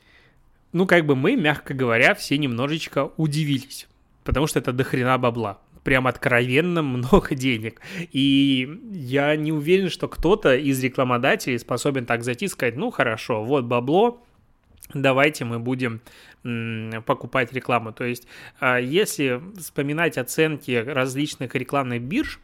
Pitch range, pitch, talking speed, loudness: 125-155 Hz, 135 Hz, 130 wpm, -22 LUFS